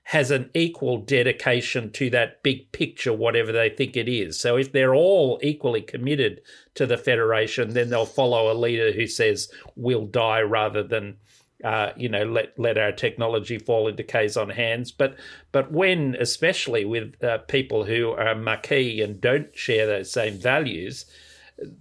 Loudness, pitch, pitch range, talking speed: -23 LUFS, 125 Hz, 115-145 Hz, 170 wpm